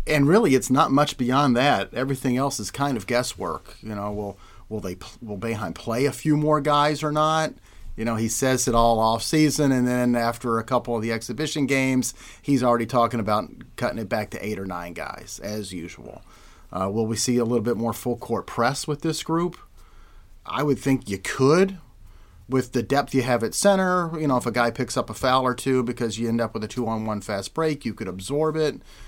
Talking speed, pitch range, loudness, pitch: 225 wpm, 110-140 Hz, -23 LUFS, 120 Hz